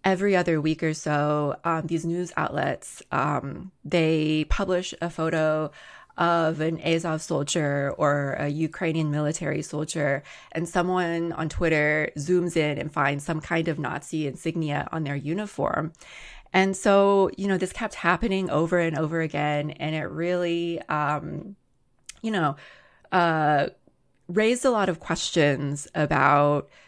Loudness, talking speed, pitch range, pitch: -25 LUFS, 140 wpm, 150-175 Hz, 160 Hz